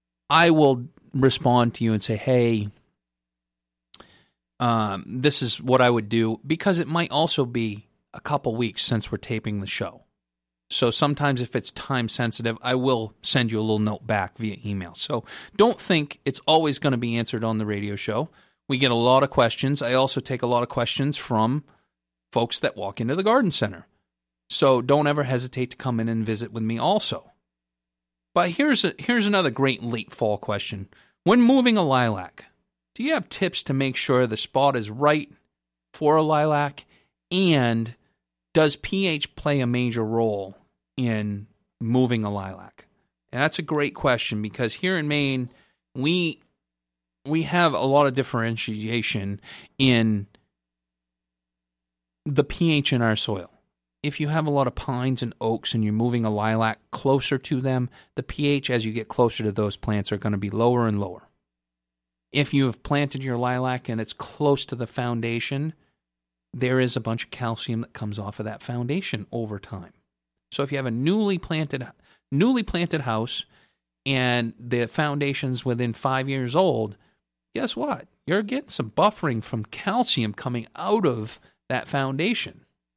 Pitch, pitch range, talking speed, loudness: 120 Hz, 105-140 Hz, 175 wpm, -24 LUFS